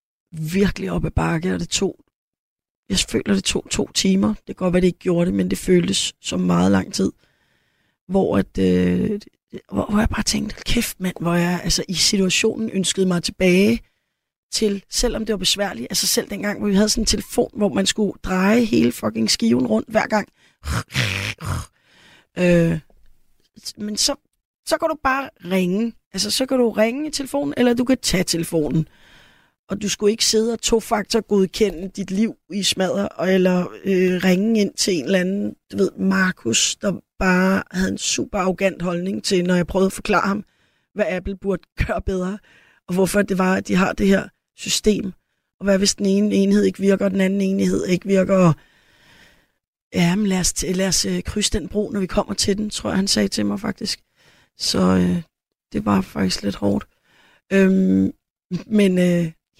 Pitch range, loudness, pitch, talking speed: 180-210 Hz, -20 LUFS, 195 Hz, 190 wpm